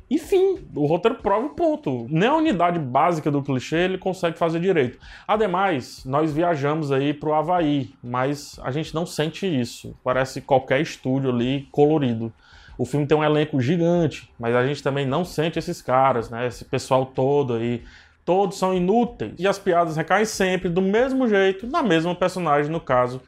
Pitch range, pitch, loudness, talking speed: 135-185 Hz, 155 Hz, -22 LUFS, 175 wpm